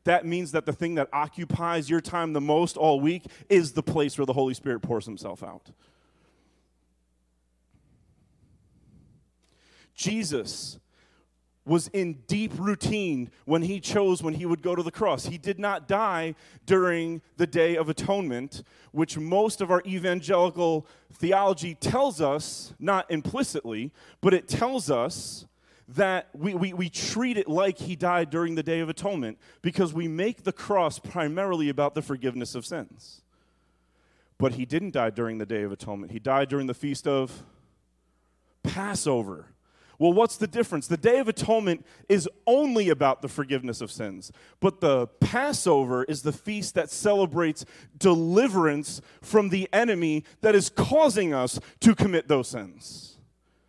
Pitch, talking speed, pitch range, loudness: 165 Hz, 155 wpm, 140-190 Hz, -26 LUFS